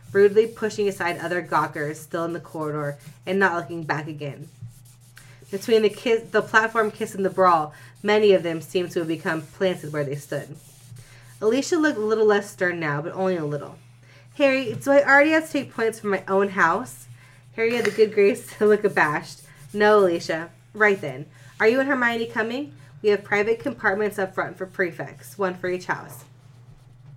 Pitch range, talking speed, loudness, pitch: 145-210 Hz, 190 wpm, -22 LUFS, 180 Hz